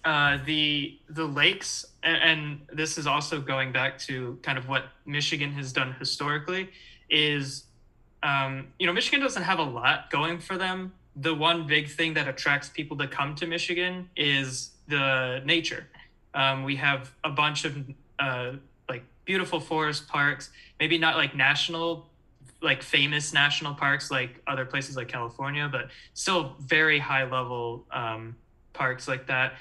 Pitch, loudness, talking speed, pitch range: 145 Hz, -26 LUFS, 160 wpm, 130-160 Hz